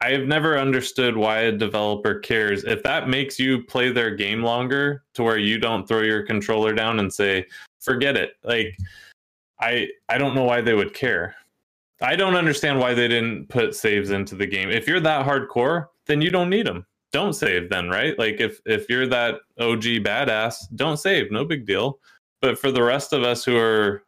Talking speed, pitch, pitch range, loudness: 200 wpm, 120 Hz, 110-135 Hz, -21 LUFS